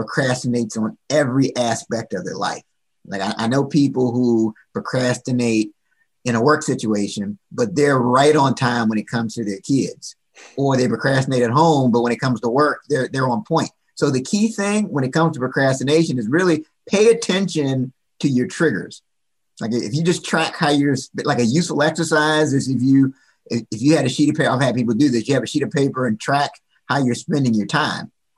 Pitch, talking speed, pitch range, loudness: 135 Hz, 210 wpm, 125-155 Hz, -19 LUFS